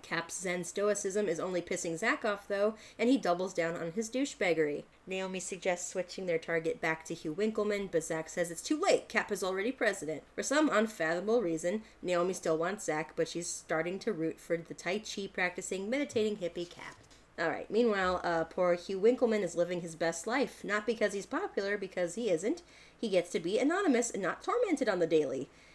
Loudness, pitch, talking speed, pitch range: -33 LUFS, 185 Hz, 200 wpm, 170-215 Hz